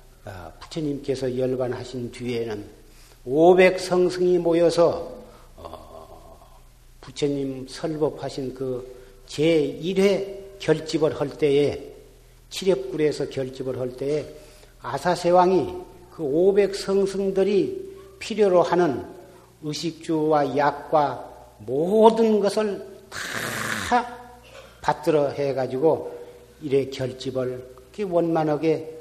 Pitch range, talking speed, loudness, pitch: 130-185 Hz, 185 characters per minute, -23 LUFS, 155 Hz